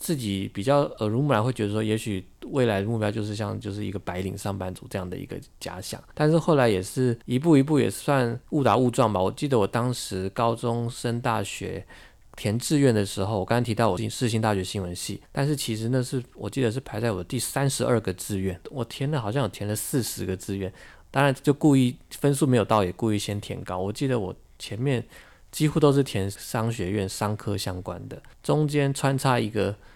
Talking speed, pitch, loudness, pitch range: 320 characters per minute, 115 Hz, -26 LUFS, 100-130 Hz